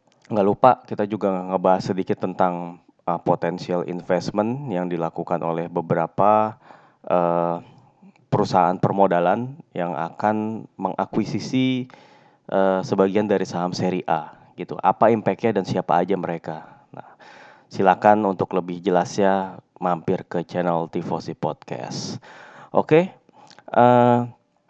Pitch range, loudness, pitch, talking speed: 90-110 Hz, -22 LUFS, 95 Hz, 110 wpm